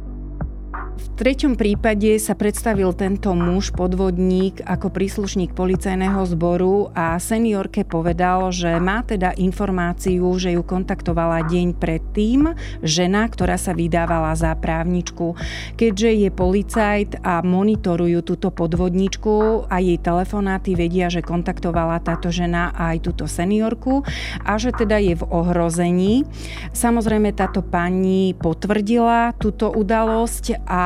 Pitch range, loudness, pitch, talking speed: 175-210 Hz, -20 LUFS, 185 Hz, 120 wpm